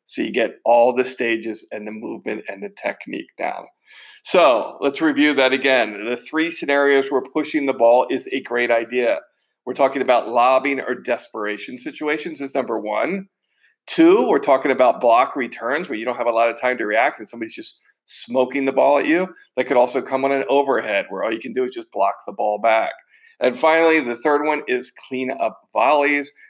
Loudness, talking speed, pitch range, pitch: -19 LUFS, 205 wpm, 120-150 Hz, 135 Hz